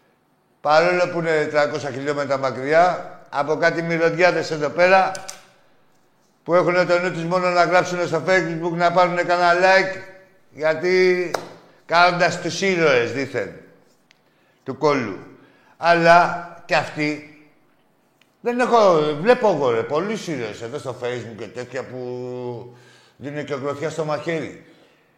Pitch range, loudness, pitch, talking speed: 145-180 Hz, -19 LUFS, 165 Hz, 125 wpm